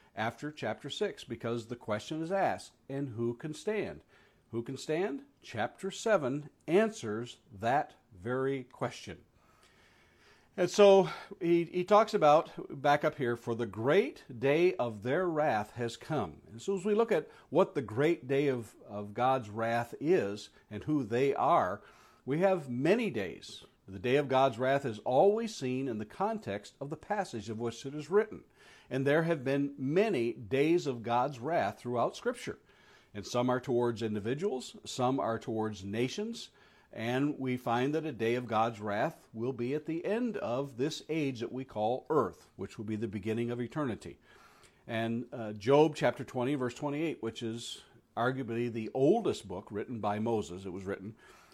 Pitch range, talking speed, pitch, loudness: 115-155 Hz, 170 wpm, 130 Hz, -32 LUFS